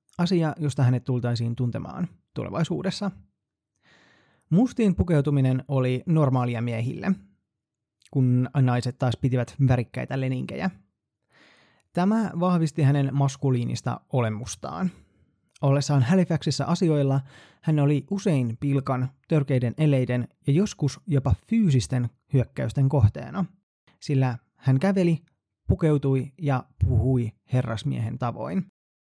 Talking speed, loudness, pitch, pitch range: 95 wpm, -25 LUFS, 135 Hz, 125-160 Hz